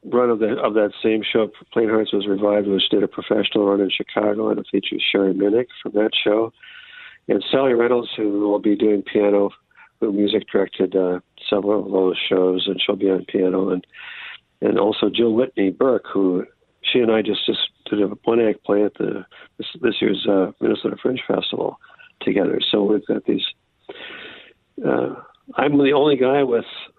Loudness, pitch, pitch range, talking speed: -20 LUFS, 105 Hz, 100-115 Hz, 185 wpm